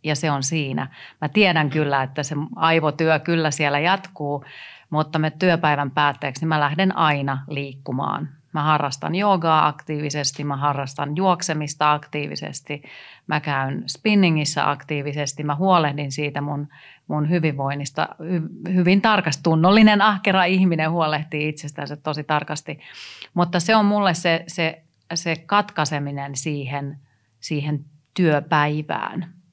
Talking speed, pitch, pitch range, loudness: 125 wpm, 150 Hz, 145-170 Hz, -21 LUFS